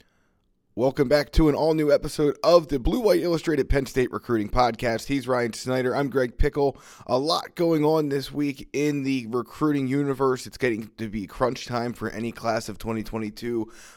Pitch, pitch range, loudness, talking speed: 130 Hz, 115-145 Hz, -25 LUFS, 185 wpm